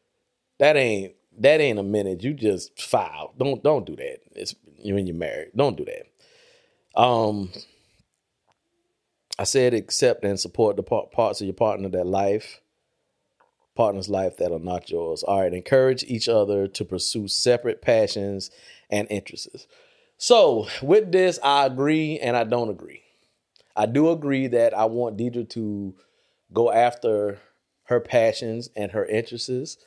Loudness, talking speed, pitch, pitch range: -23 LUFS, 150 wpm, 120 Hz, 105-155 Hz